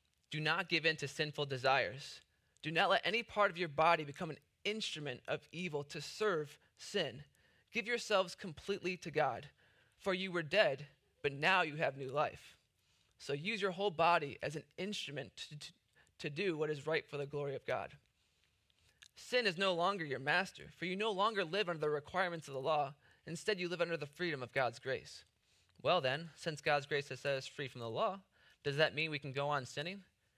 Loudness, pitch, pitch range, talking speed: -37 LUFS, 155 Hz, 145-185 Hz, 205 wpm